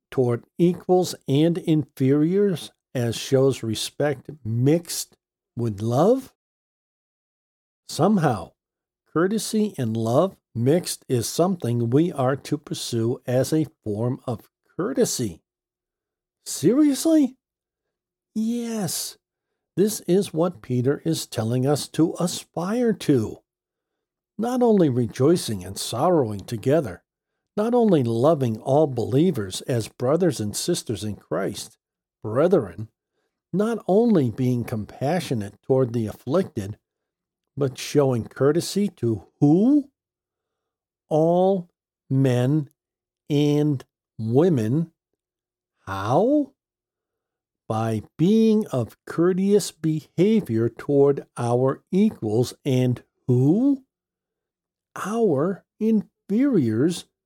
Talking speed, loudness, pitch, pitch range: 90 wpm, -23 LUFS, 150 Hz, 125-190 Hz